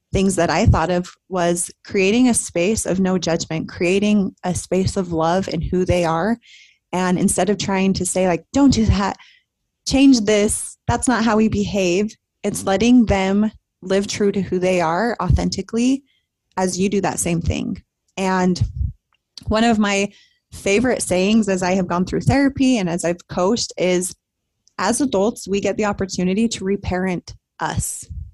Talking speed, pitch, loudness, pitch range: 170 wpm, 195 Hz, -19 LUFS, 180-215 Hz